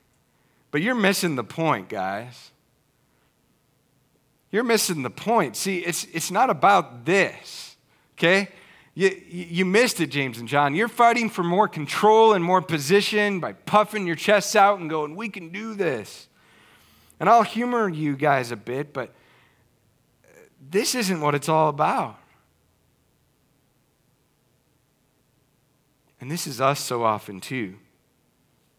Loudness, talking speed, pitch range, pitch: -22 LUFS, 135 wpm, 145-205 Hz, 170 Hz